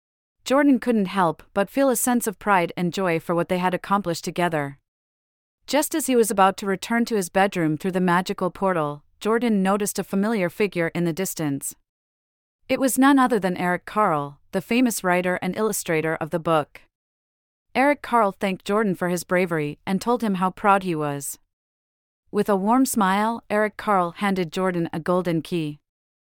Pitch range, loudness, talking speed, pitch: 165-210 Hz, -22 LUFS, 180 wpm, 185 Hz